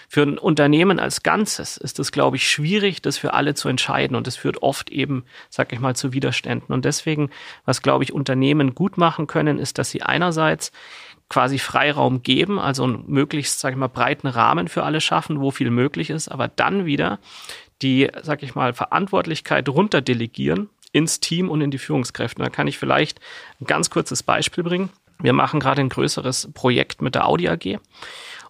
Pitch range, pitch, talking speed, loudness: 135-160 Hz, 145 Hz, 190 wpm, -20 LUFS